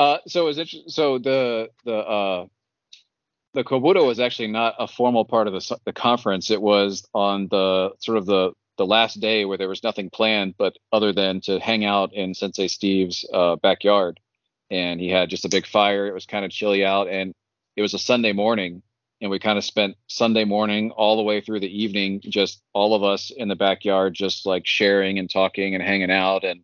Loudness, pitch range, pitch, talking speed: -21 LUFS, 95-110 Hz, 100 Hz, 210 wpm